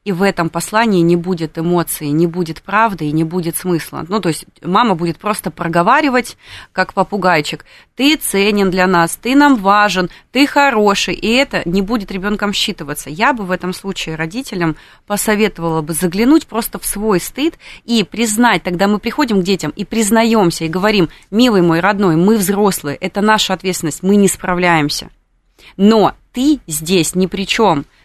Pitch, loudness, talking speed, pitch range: 195 Hz, -14 LUFS, 170 wpm, 170-215 Hz